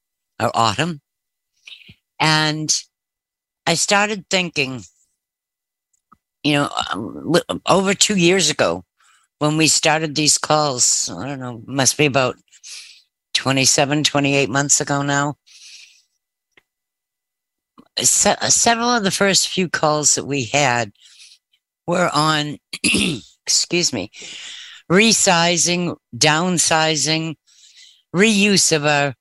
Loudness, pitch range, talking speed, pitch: -17 LUFS, 140-175 Hz, 100 wpm, 150 Hz